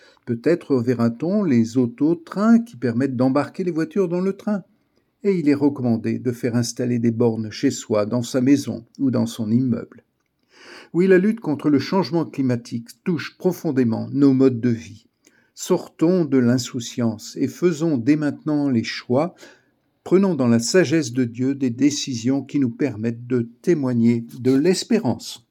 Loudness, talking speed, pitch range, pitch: -21 LUFS, 160 wpm, 120-165 Hz, 135 Hz